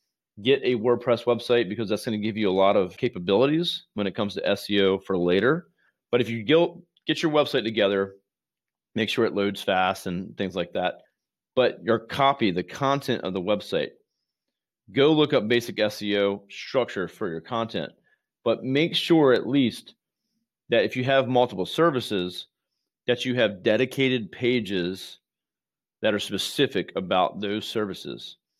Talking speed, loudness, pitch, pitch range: 160 wpm, -24 LUFS, 115 Hz, 100-135 Hz